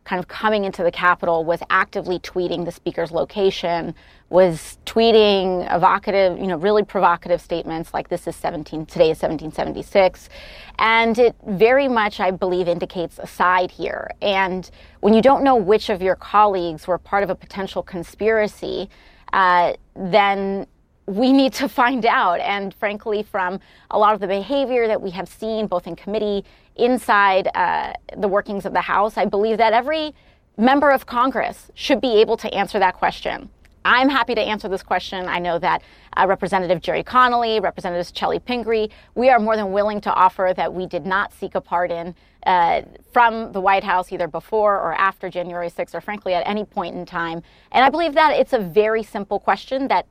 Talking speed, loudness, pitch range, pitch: 185 wpm, -19 LUFS, 180-220 Hz, 195 Hz